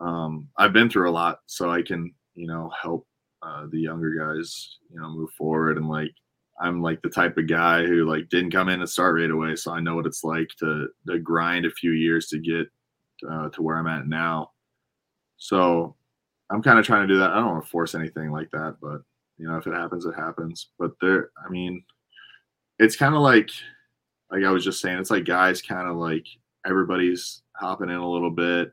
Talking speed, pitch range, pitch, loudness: 220 wpm, 80-90 Hz, 85 Hz, -23 LUFS